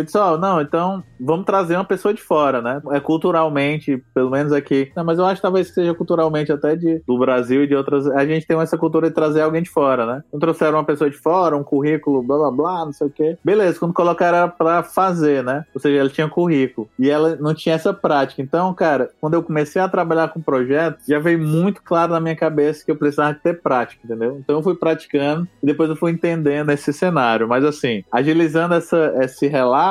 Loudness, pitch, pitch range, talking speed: -18 LUFS, 155 Hz, 145-170 Hz, 230 wpm